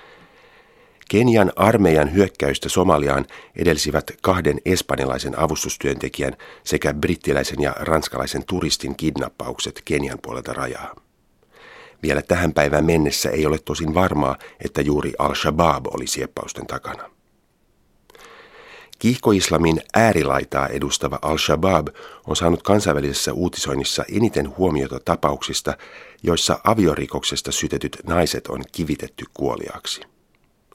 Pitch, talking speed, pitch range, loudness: 75 Hz, 95 wpm, 70-95 Hz, -20 LUFS